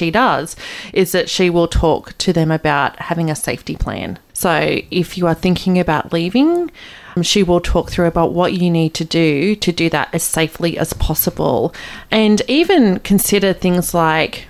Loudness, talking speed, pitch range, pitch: -16 LUFS, 175 wpm, 165-190 Hz, 175 Hz